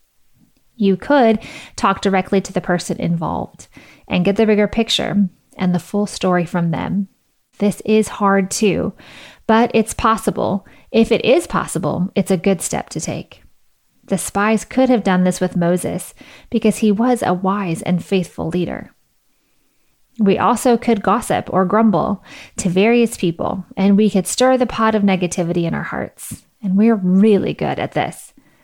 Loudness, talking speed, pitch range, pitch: -17 LUFS, 165 wpm, 185-220 Hz, 200 Hz